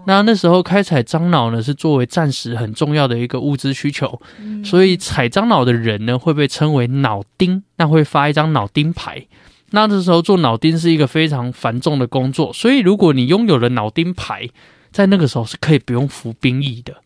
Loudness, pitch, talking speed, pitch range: -15 LUFS, 150 Hz, 310 characters per minute, 125-175 Hz